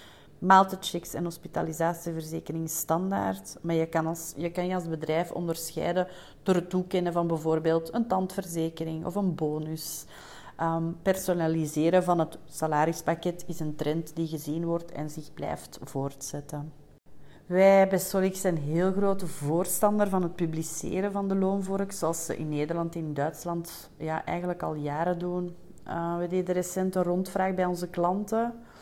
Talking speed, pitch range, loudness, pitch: 150 wpm, 160-185 Hz, -29 LUFS, 170 Hz